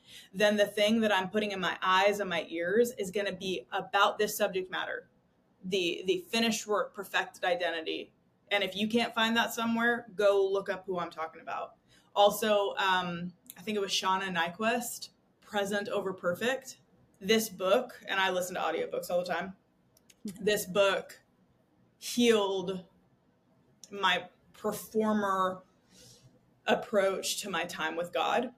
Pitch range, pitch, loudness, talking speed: 185-215 Hz, 200 Hz, -30 LUFS, 150 wpm